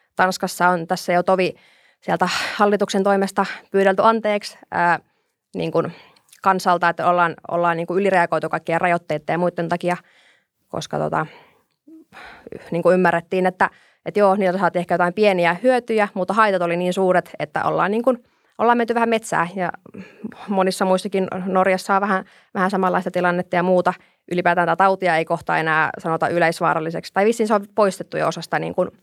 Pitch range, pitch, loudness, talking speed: 175-200 Hz, 185 Hz, -20 LUFS, 160 wpm